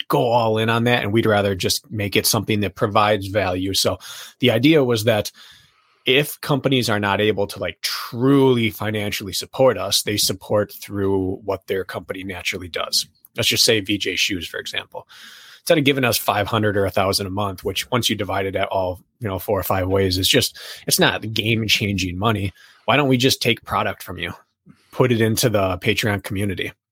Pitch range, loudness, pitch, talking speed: 100-115 Hz, -20 LUFS, 105 Hz, 200 wpm